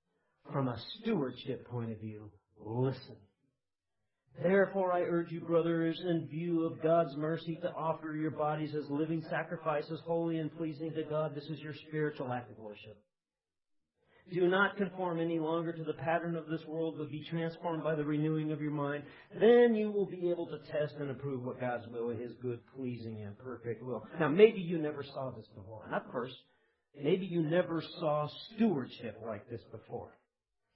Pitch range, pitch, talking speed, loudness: 125-165 Hz, 155 Hz, 180 wpm, -34 LUFS